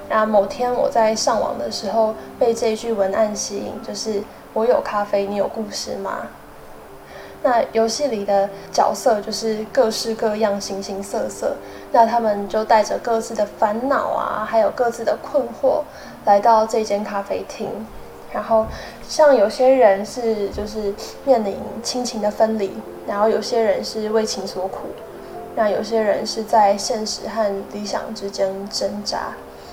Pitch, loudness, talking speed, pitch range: 220 Hz, -20 LUFS, 230 characters per minute, 200-230 Hz